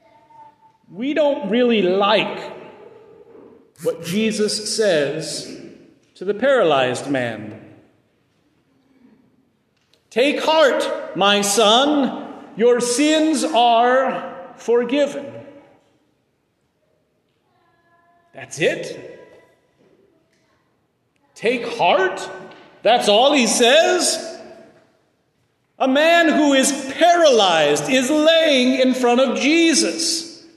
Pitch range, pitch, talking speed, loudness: 240-330 Hz, 275 Hz, 75 wpm, -17 LUFS